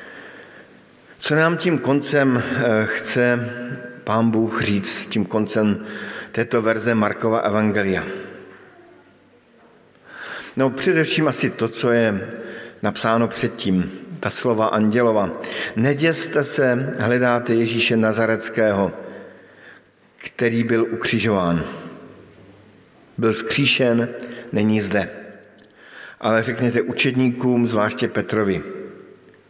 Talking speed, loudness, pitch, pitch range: 85 wpm, -20 LUFS, 115 Hz, 110-125 Hz